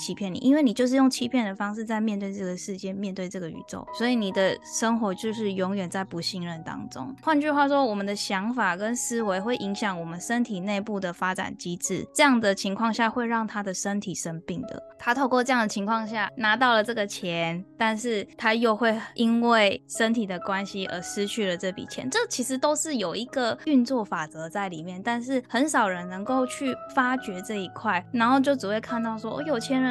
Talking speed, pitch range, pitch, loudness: 320 characters per minute, 190-250 Hz, 220 Hz, -26 LUFS